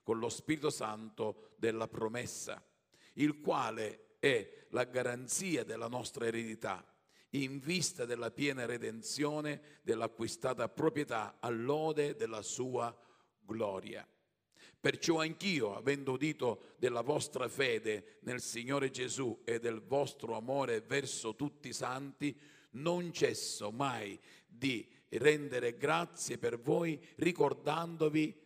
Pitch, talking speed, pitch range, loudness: 140 Hz, 110 wpm, 120-155 Hz, -37 LUFS